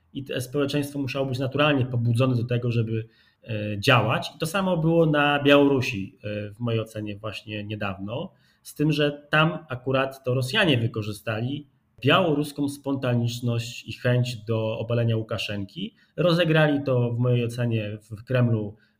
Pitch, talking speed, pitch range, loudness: 125 Hz, 135 wpm, 110-145 Hz, -24 LUFS